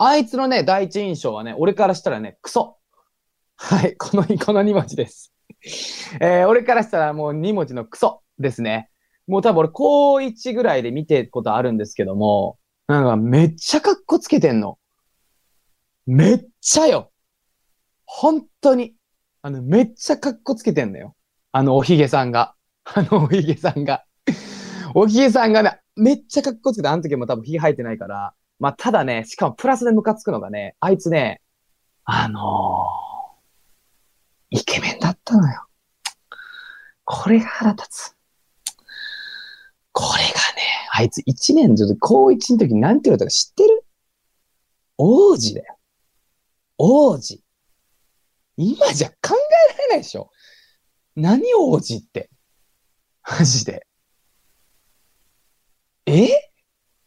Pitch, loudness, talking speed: 205 Hz, -18 LUFS, 270 characters per minute